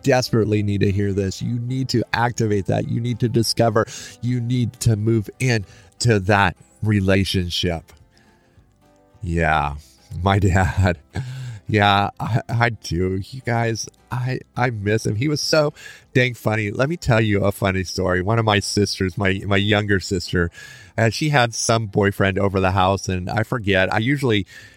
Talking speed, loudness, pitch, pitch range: 165 wpm, -20 LUFS, 105 Hz, 95-120 Hz